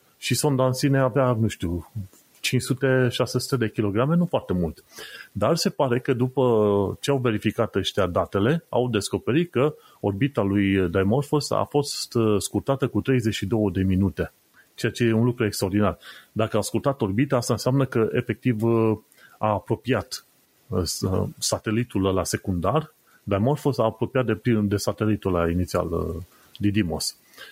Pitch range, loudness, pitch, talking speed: 100-130 Hz, -24 LUFS, 110 Hz, 140 wpm